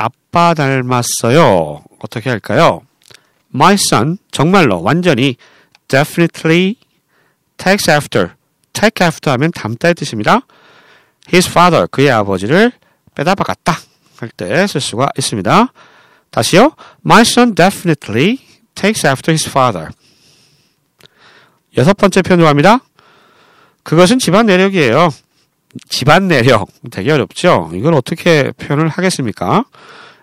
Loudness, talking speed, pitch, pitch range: -12 LUFS, 335 characters per minute, 165 Hz, 140-195 Hz